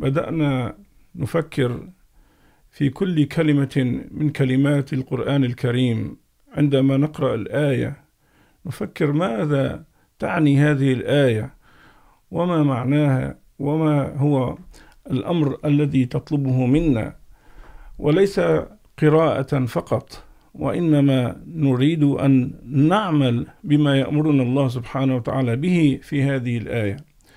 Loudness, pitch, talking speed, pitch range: -20 LUFS, 140 Hz, 90 wpm, 130-150 Hz